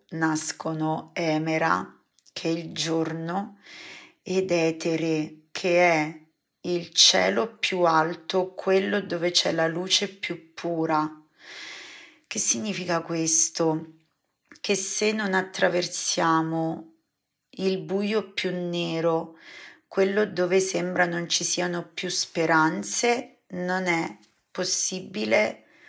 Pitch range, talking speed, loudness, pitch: 160-190 Hz, 100 wpm, -25 LUFS, 175 Hz